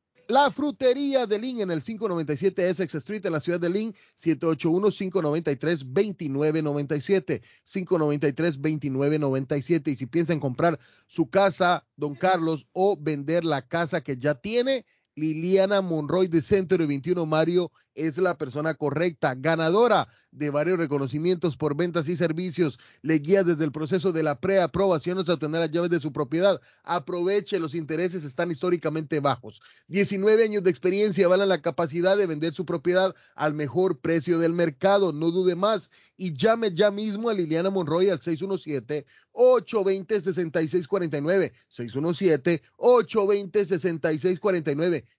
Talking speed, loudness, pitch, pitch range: 140 wpm, -25 LUFS, 175 Hz, 155-190 Hz